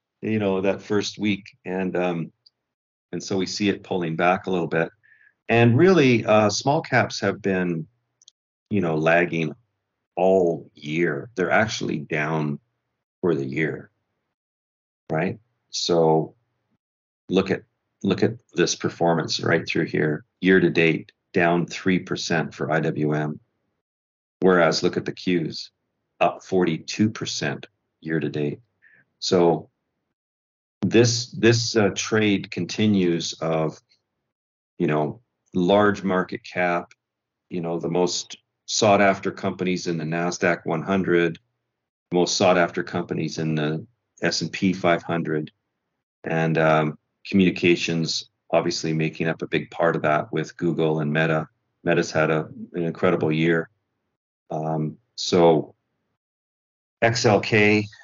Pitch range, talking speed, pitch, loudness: 80-95 Hz, 120 wpm, 85 Hz, -22 LUFS